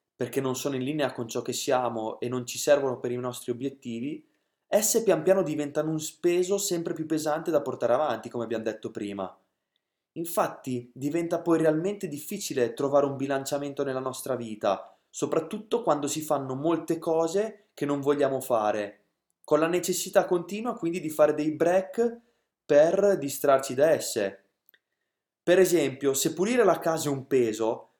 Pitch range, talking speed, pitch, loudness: 130-175 Hz, 165 wpm, 150 Hz, -27 LUFS